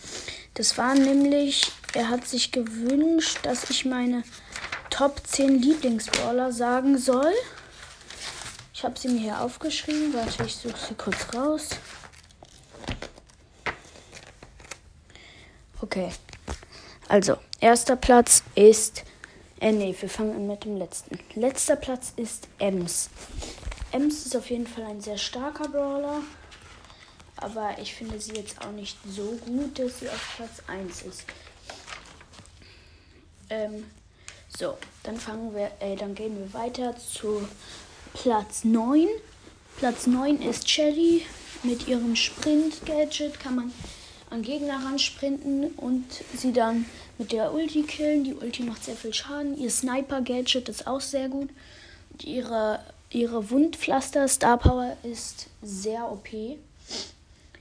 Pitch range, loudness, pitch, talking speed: 220-280 Hz, -26 LUFS, 245 Hz, 125 wpm